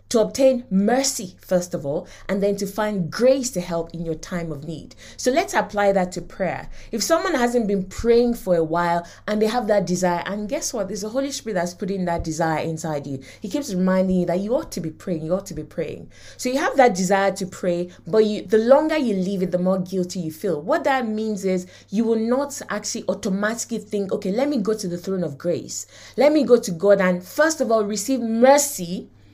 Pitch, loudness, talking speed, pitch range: 200 Hz, -22 LUFS, 235 wpm, 180-235 Hz